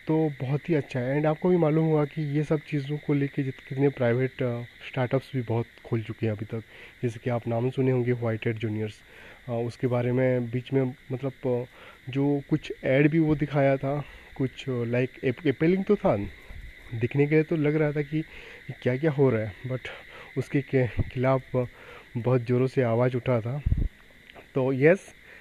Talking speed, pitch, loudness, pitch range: 185 wpm, 130 Hz, -27 LUFS, 125-145 Hz